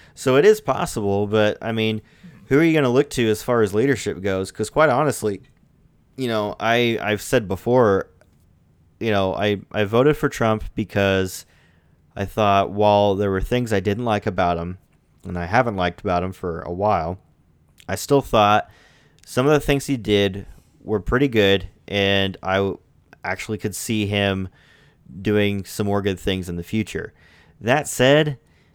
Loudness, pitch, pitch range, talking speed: -20 LUFS, 105 Hz, 95-120 Hz, 175 wpm